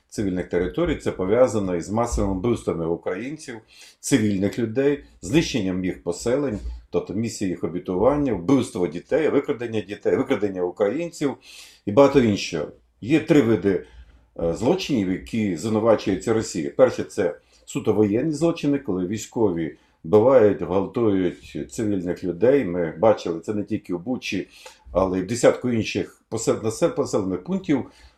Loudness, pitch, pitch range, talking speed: -23 LUFS, 110 Hz, 95-140 Hz, 125 wpm